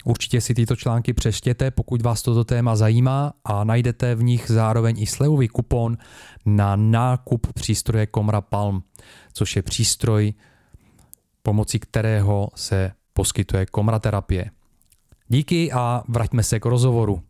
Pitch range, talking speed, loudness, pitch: 105-120 Hz, 130 wpm, -21 LUFS, 115 Hz